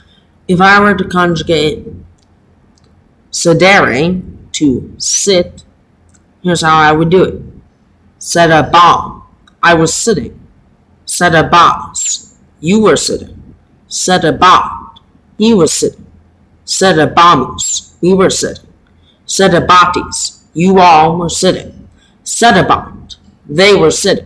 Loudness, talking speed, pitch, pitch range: -9 LUFS, 100 wpm, 170 Hz, 155-185 Hz